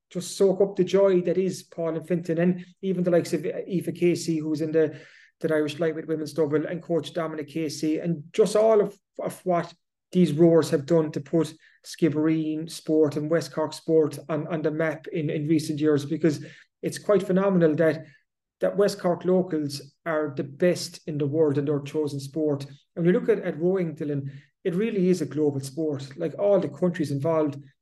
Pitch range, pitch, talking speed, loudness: 155-175 Hz, 160 Hz, 200 wpm, -25 LUFS